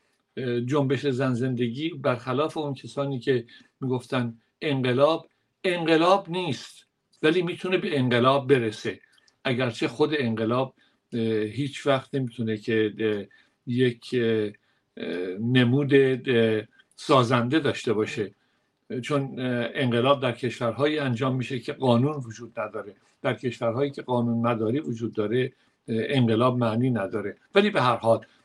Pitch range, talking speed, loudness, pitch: 115-140 Hz, 110 wpm, -25 LUFS, 125 Hz